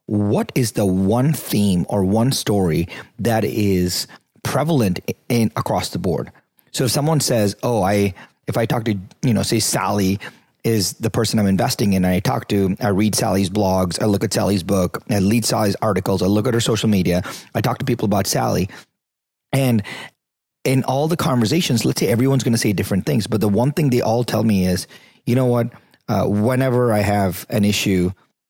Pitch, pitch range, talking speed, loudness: 110 Hz, 100-125 Hz, 200 wpm, -19 LUFS